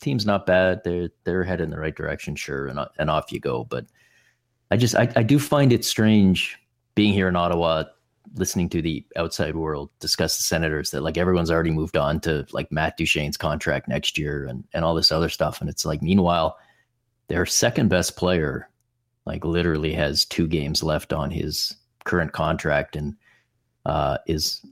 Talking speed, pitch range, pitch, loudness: 185 wpm, 80-100 Hz, 85 Hz, -23 LUFS